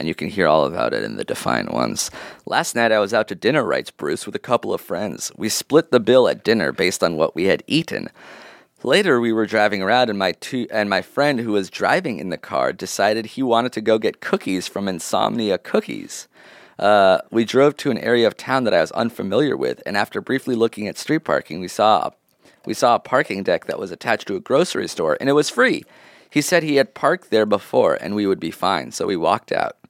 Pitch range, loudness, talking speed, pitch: 100-135 Hz, -20 LUFS, 235 wpm, 115 Hz